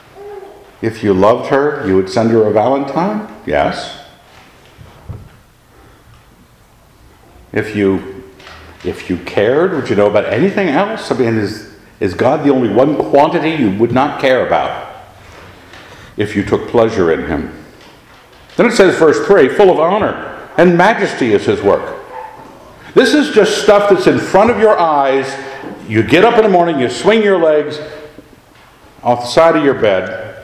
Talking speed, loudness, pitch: 160 wpm, -12 LUFS, 140 Hz